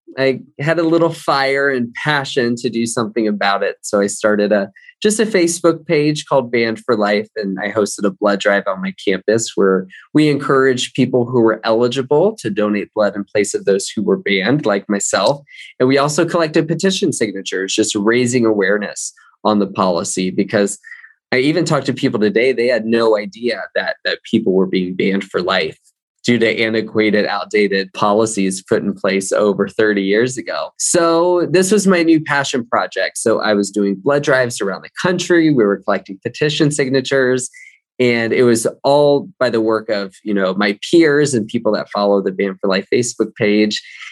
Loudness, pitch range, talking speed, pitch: -16 LUFS, 100-145 Hz, 190 wpm, 115 Hz